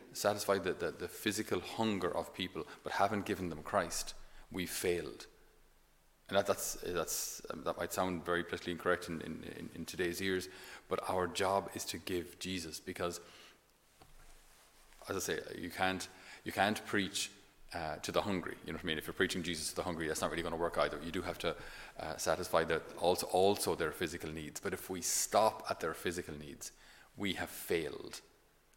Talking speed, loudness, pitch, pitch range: 195 wpm, -37 LUFS, 90 Hz, 85-95 Hz